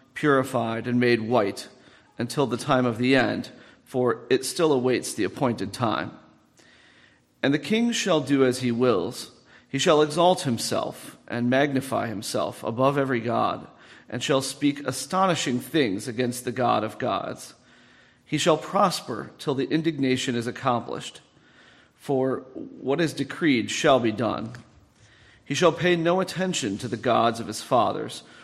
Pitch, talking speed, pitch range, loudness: 130 Hz, 150 wpm, 120-150 Hz, -24 LUFS